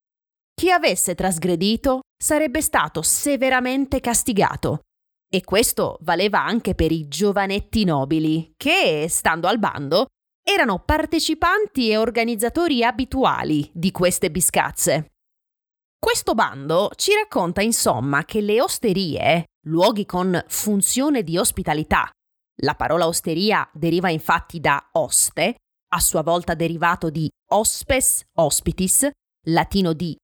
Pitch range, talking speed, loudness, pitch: 170-265 Hz, 110 wpm, -20 LUFS, 205 Hz